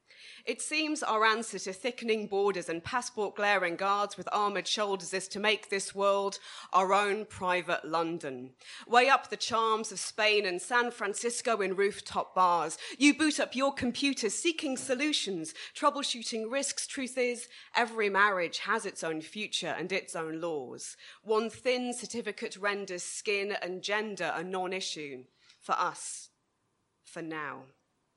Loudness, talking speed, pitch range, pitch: -31 LUFS, 150 wpm, 185-235 Hz, 205 Hz